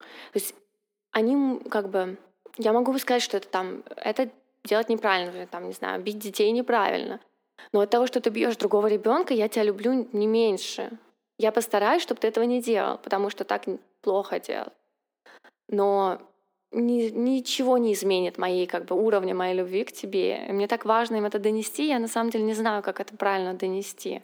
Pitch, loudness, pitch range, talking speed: 220 Hz, -26 LUFS, 195-240 Hz, 185 wpm